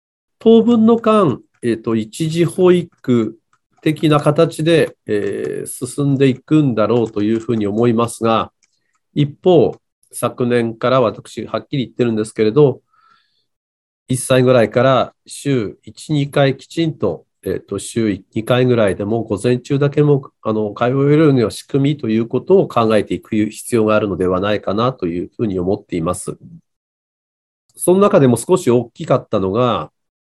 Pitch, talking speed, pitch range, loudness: 125 Hz, 290 characters per minute, 110-150 Hz, -16 LUFS